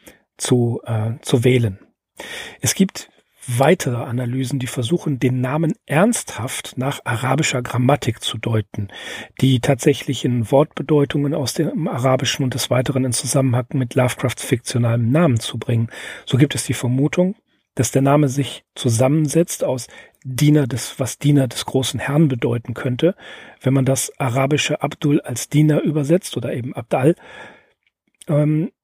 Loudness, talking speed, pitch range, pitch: -19 LUFS, 140 wpm, 125-150 Hz, 135 Hz